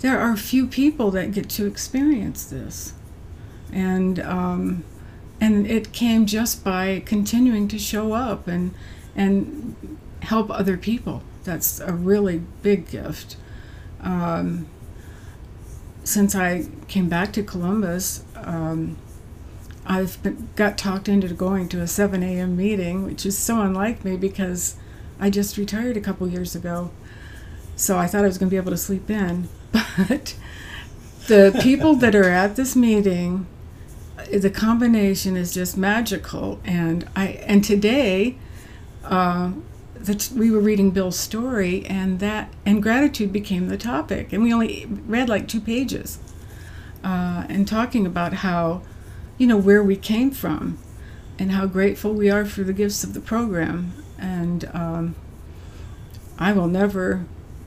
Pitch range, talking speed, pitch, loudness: 170-210 Hz, 145 wpm, 190 Hz, -21 LUFS